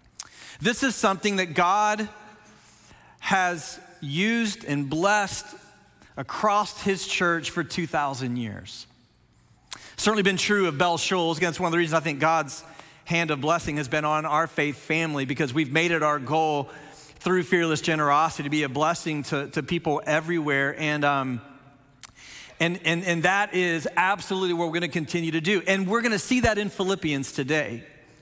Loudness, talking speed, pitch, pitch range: -24 LUFS, 170 wpm, 165 Hz, 150-185 Hz